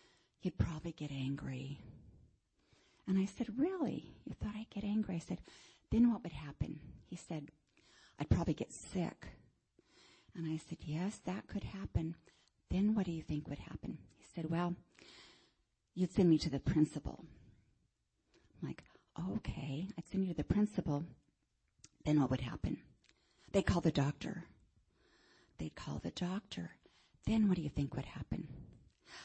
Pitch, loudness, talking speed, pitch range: 165 Hz, -39 LUFS, 155 wpm, 140-195 Hz